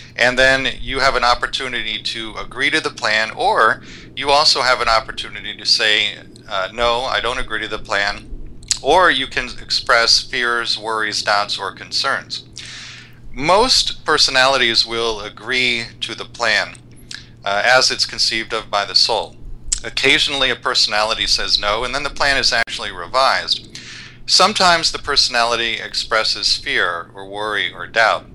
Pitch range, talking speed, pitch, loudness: 105-125 Hz, 150 wpm, 115 Hz, -16 LUFS